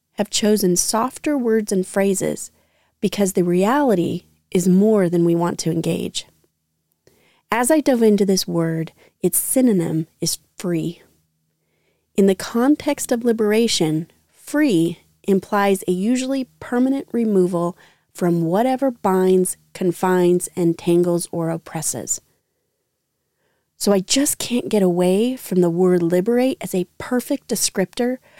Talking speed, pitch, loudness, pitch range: 125 wpm, 185 Hz, -19 LUFS, 170-225 Hz